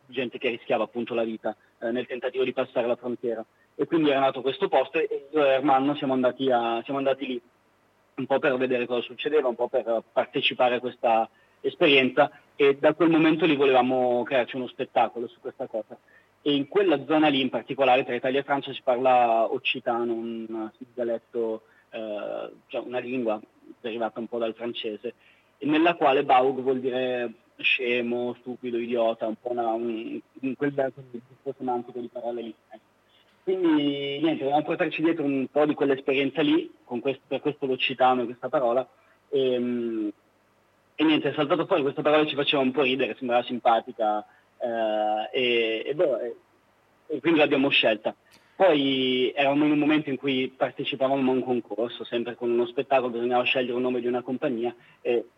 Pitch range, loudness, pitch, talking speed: 120-140 Hz, -25 LUFS, 130 Hz, 175 wpm